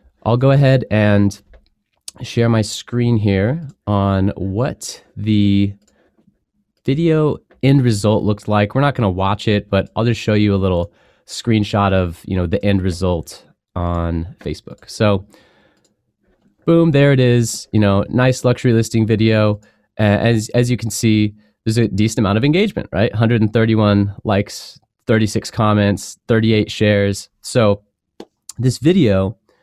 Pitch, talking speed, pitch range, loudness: 105 Hz, 140 wpm, 100-120 Hz, -16 LUFS